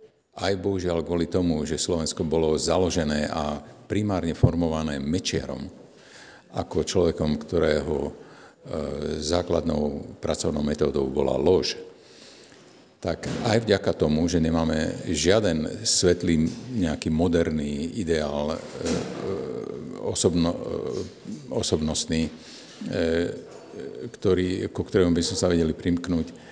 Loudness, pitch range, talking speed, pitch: -25 LUFS, 80-90 Hz, 90 wpm, 80 Hz